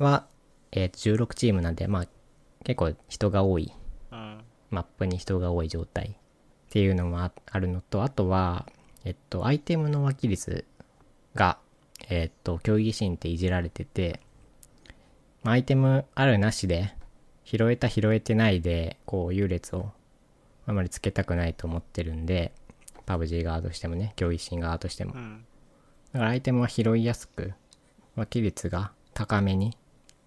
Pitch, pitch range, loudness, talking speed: 95 Hz, 85-115 Hz, -28 LUFS, 290 characters per minute